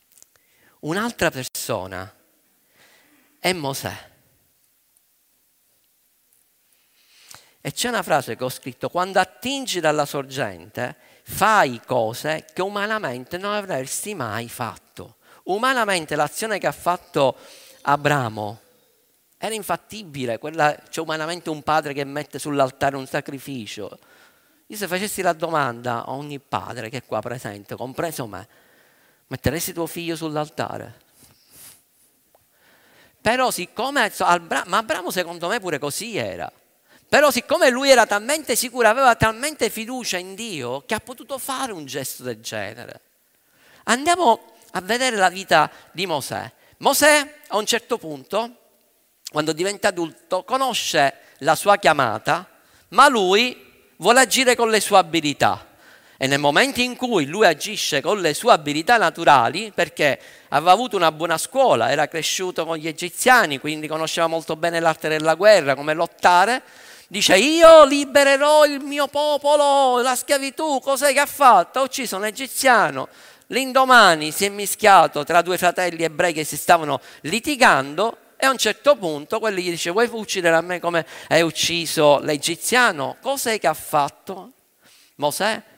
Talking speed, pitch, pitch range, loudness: 140 wpm, 180 Hz, 150-235 Hz, -19 LUFS